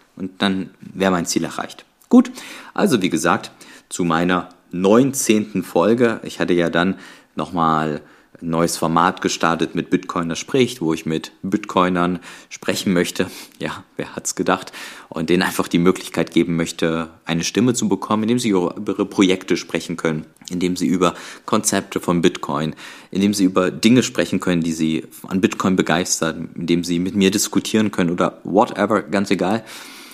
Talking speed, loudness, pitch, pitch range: 165 wpm, -19 LUFS, 90 Hz, 85-95 Hz